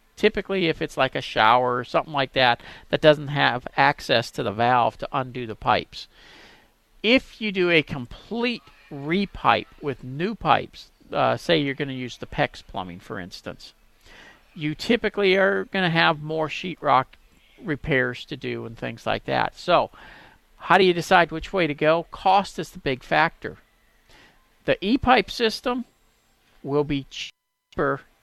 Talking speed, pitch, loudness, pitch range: 165 wpm, 155 Hz, -23 LUFS, 130-190 Hz